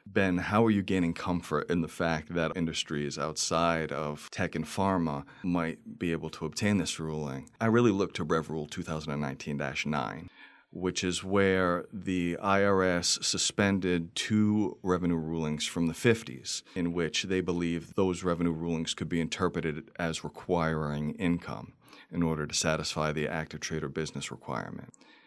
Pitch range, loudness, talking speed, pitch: 80-90 Hz, -30 LUFS, 155 wpm, 85 Hz